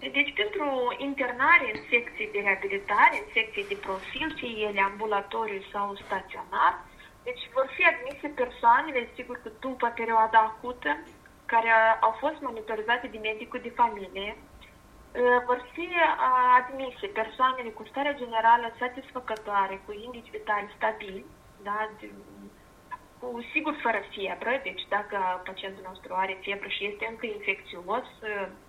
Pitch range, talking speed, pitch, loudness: 205-255 Hz, 130 wpm, 230 Hz, -27 LUFS